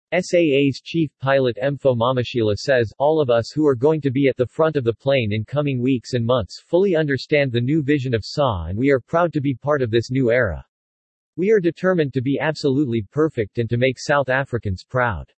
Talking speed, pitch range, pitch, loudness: 220 wpm, 120-150 Hz, 135 Hz, -20 LUFS